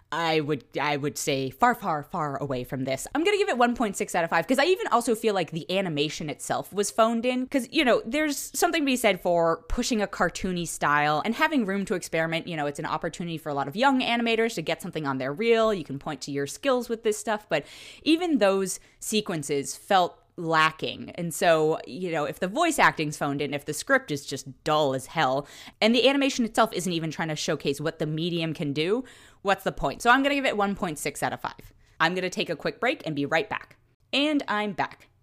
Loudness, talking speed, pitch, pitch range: -26 LUFS, 240 wpm, 175 Hz, 150-230 Hz